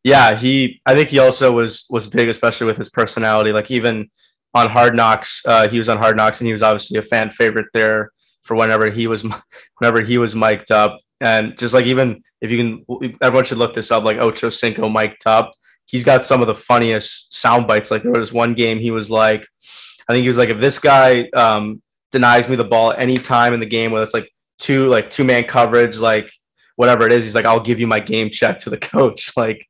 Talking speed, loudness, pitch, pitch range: 240 wpm, -15 LUFS, 115 Hz, 110-120 Hz